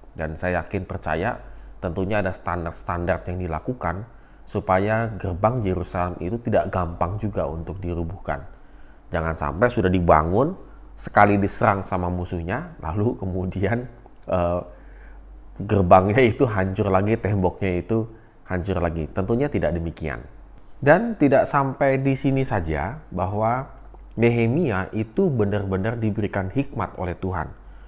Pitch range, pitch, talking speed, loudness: 90-115 Hz, 95 Hz, 115 wpm, -23 LUFS